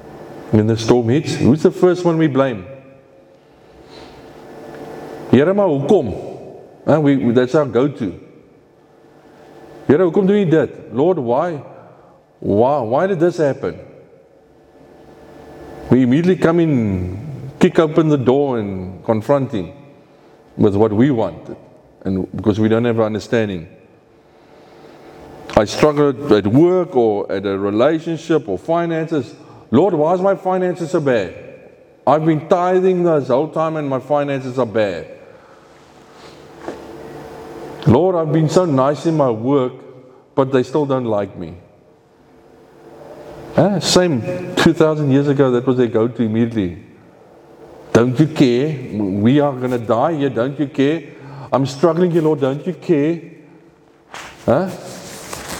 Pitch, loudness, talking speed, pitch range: 145 Hz, -16 LUFS, 135 wpm, 120-160 Hz